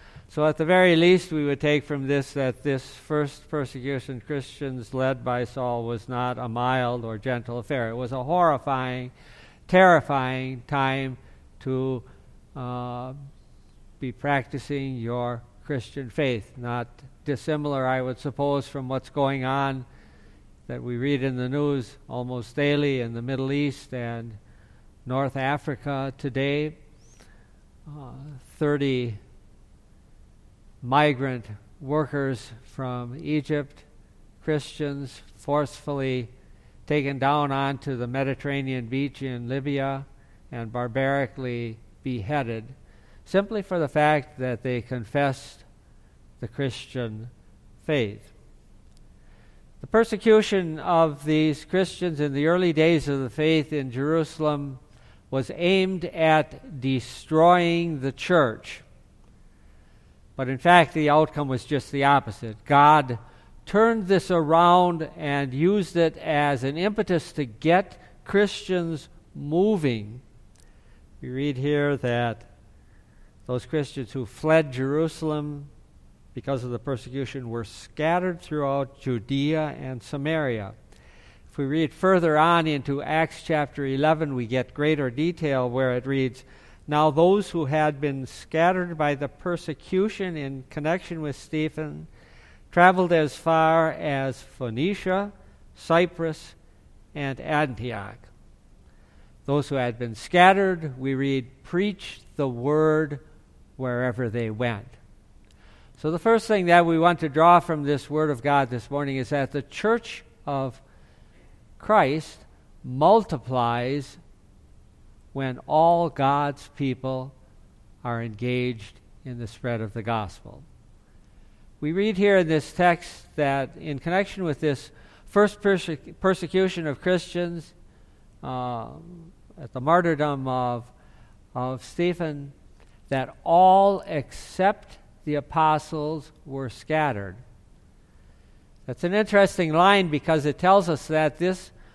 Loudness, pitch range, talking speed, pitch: -24 LUFS, 125-160 Hz, 120 wpm, 140 Hz